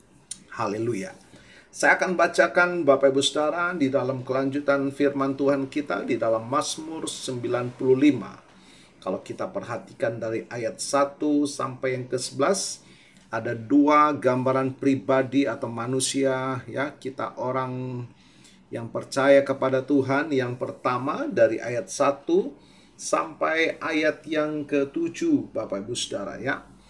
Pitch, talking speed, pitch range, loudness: 135 Hz, 115 wpm, 130-150 Hz, -25 LUFS